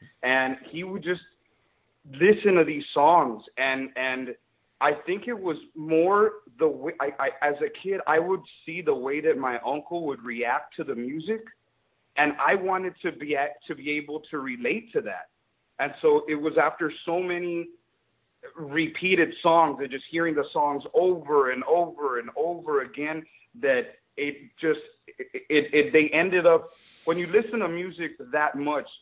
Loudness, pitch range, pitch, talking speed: -25 LUFS, 145-185 Hz, 165 Hz, 175 wpm